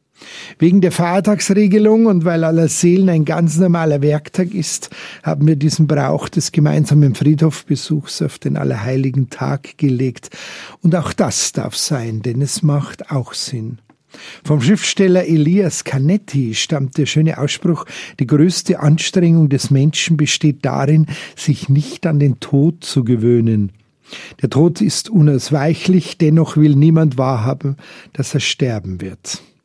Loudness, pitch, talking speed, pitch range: -15 LUFS, 150 Hz, 140 wpm, 140-170 Hz